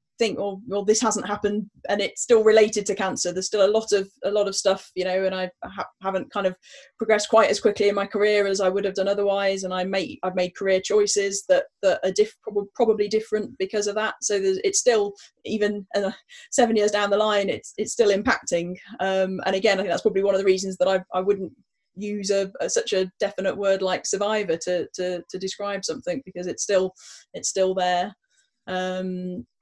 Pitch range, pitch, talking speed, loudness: 190-215 Hz, 200 Hz, 225 wpm, -23 LUFS